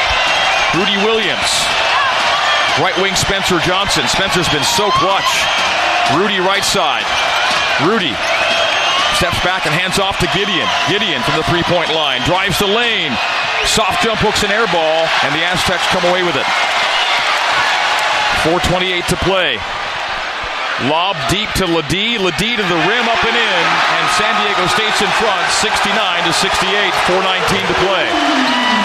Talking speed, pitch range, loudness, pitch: 145 wpm, 170-220 Hz, -13 LUFS, 185 Hz